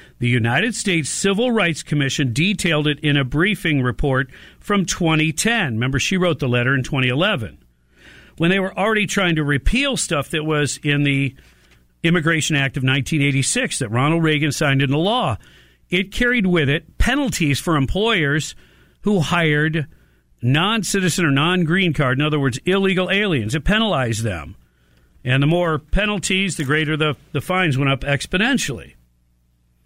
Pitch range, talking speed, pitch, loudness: 130-185 Hz, 155 wpm, 150 Hz, -19 LUFS